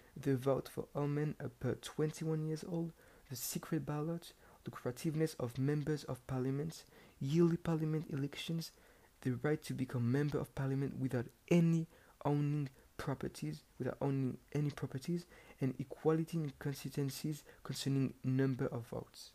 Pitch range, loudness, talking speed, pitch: 130-155 Hz, -39 LUFS, 145 wpm, 145 Hz